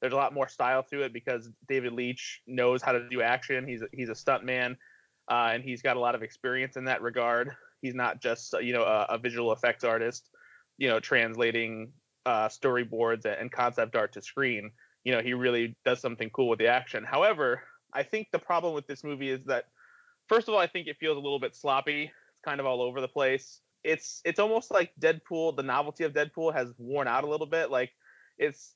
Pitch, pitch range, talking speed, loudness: 130 Hz, 120-150 Hz, 220 wpm, -30 LUFS